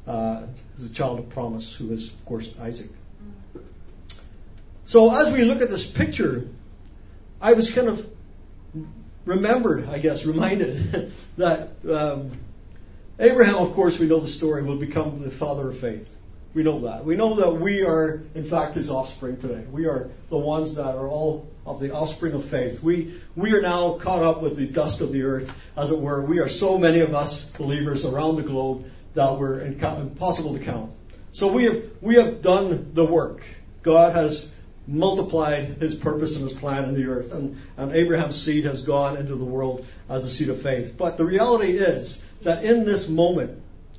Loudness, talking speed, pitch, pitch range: -23 LUFS, 185 wpm, 145 Hz, 125-165 Hz